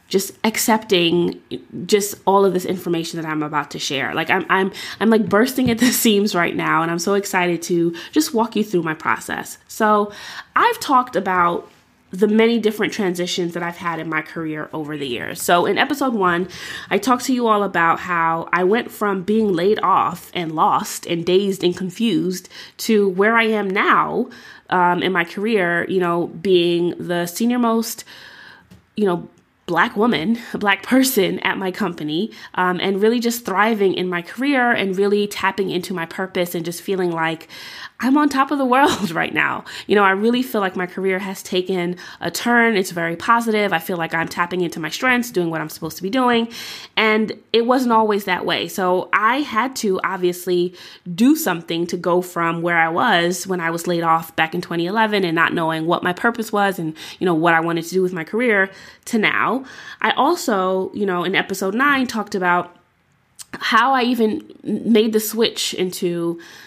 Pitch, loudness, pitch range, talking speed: 190 Hz, -19 LUFS, 175-220 Hz, 195 wpm